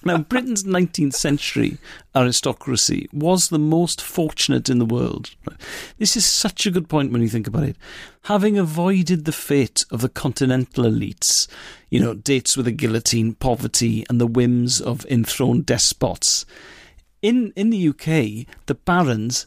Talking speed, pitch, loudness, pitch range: 155 wpm, 145 Hz, -19 LUFS, 120-180 Hz